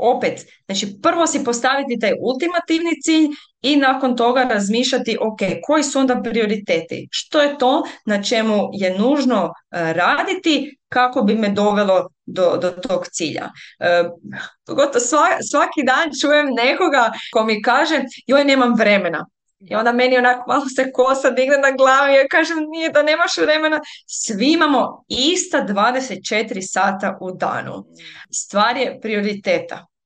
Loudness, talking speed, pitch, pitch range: -17 LUFS, 145 wpm, 255 Hz, 210-290 Hz